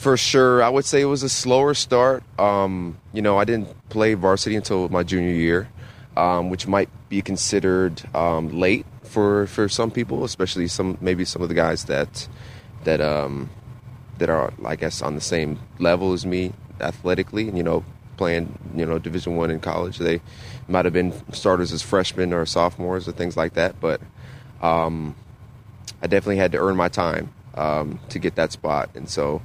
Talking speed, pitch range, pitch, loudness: 185 wpm, 85-110 Hz, 95 Hz, -22 LUFS